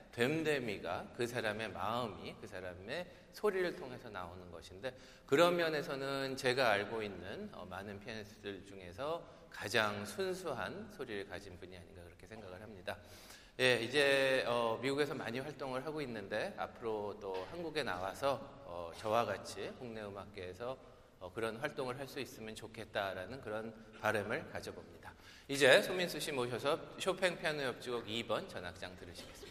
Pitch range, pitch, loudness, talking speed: 100-135 Hz, 115 Hz, -38 LUFS, 345 characters per minute